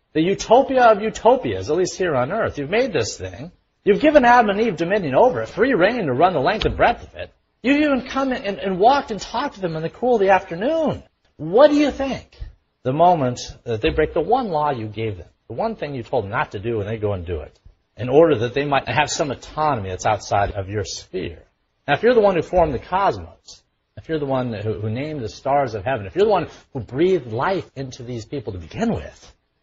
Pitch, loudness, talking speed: 150 Hz, -20 LUFS, 250 wpm